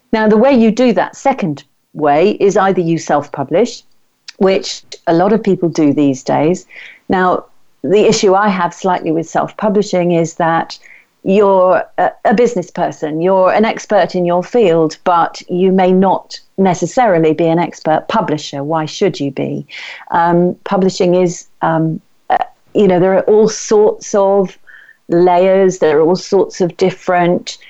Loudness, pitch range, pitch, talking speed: -13 LUFS, 165-200 Hz, 180 Hz, 160 wpm